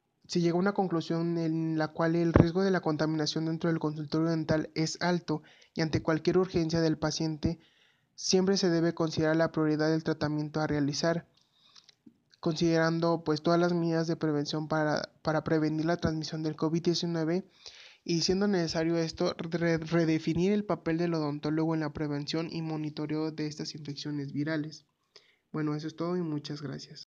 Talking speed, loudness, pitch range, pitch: 165 wpm, -30 LUFS, 155-170 Hz, 160 Hz